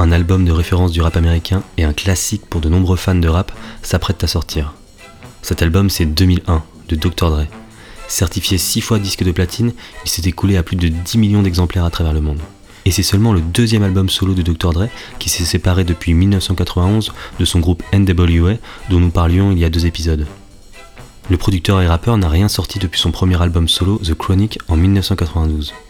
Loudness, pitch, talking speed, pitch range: -15 LUFS, 90 Hz, 205 wpm, 85-100 Hz